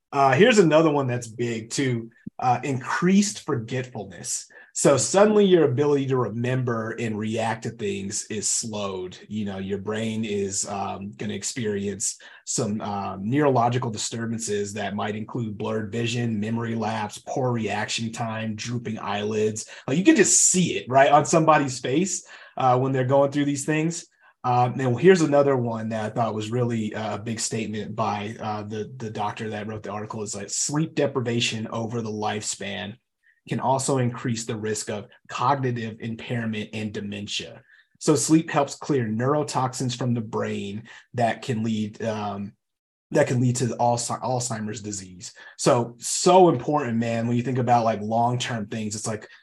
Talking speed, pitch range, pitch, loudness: 165 wpm, 110-130 Hz, 115 Hz, -24 LUFS